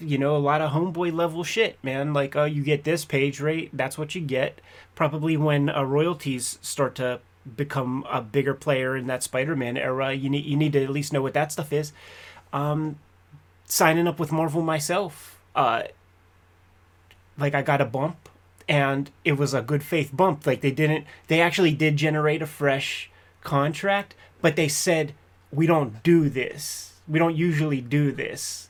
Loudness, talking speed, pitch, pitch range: -24 LUFS, 185 wpm, 145 Hz, 135-155 Hz